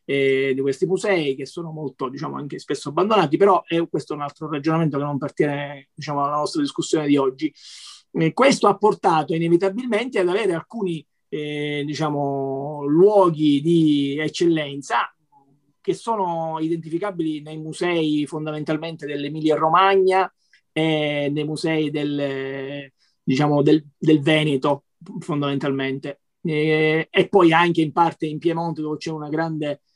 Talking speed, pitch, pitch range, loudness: 140 wpm, 155 Hz, 145-170 Hz, -21 LUFS